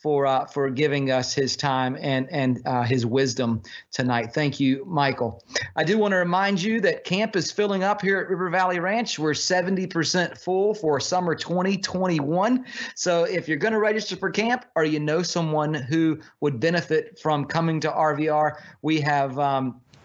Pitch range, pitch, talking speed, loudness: 140-185 Hz, 155 Hz, 190 wpm, -24 LUFS